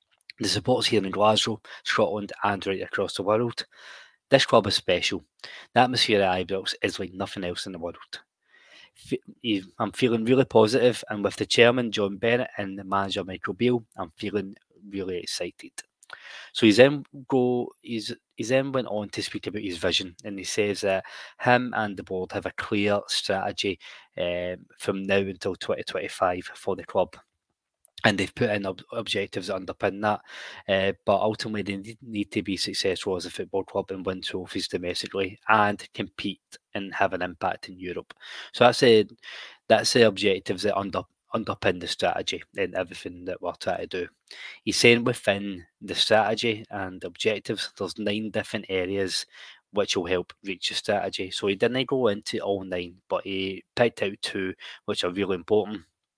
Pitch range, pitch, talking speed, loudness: 95-110 Hz, 100 Hz, 175 wpm, -26 LUFS